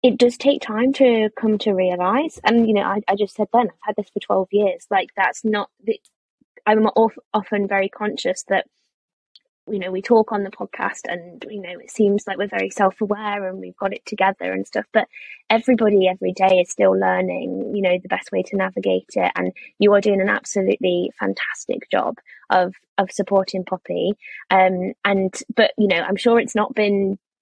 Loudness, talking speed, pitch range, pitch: -20 LUFS, 200 wpm, 185-215 Hz, 200 Hz